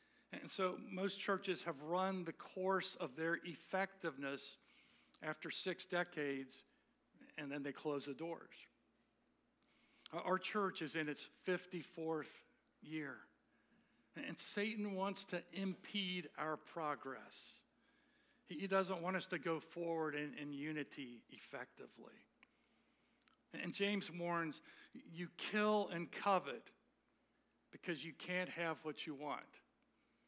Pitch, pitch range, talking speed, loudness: 170 Hz, 155-185 Hz, 115 wpm, -44 LUFS